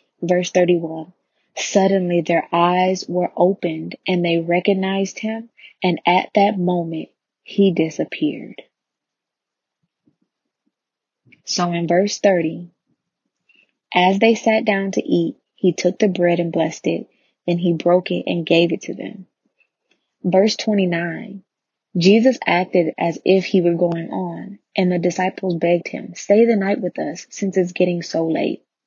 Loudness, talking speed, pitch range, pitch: -19 LUFS, 140 wpm, 175-195 Hz, 180 Hz